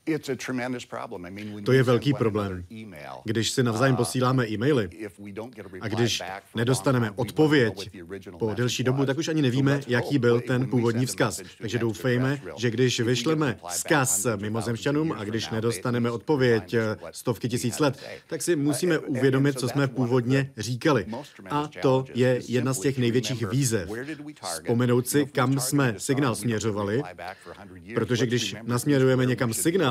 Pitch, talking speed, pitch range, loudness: 125 Hz, 130 wpm, 115-135 Hz, -25 LUFS